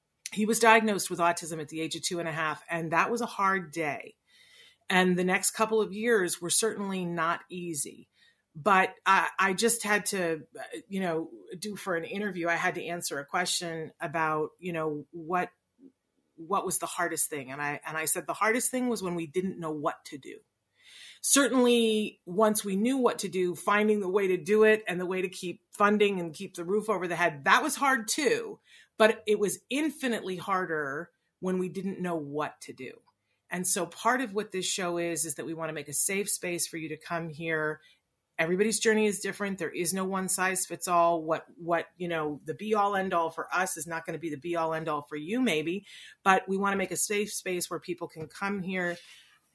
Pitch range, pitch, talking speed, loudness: 165-210 Hz, 185 Hz, 225 wpm, -28 LUFS